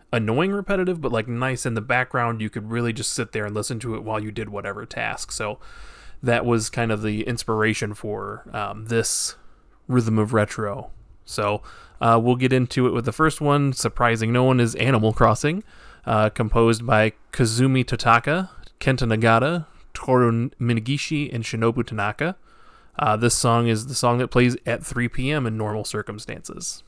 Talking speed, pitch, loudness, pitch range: 170 wpm, 120 Hz, -22 LUFS, 110-125 Hz